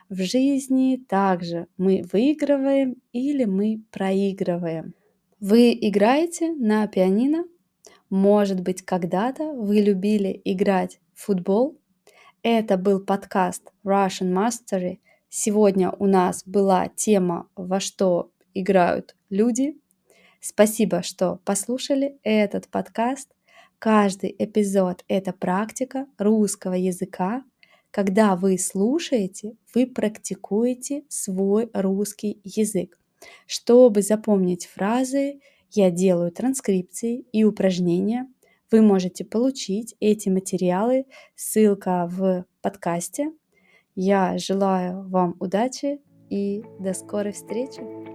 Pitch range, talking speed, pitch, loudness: 185-235 Hz, 95 wpm, 200 Hz, -22 LUFS